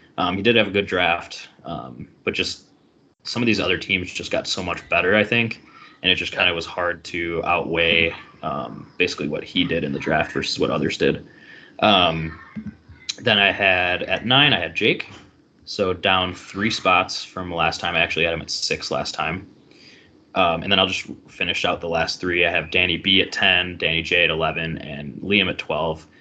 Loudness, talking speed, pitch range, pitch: -20 LUFS, 210 wpm, 85-95 Hz, 90 Hz